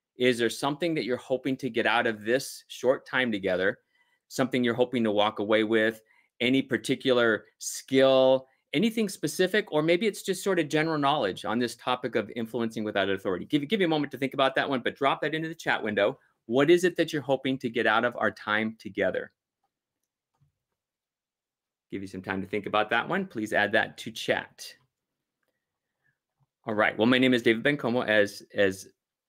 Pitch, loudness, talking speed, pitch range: 130 Hz, -27 LUFS, 195 wpm, 110-155 Hz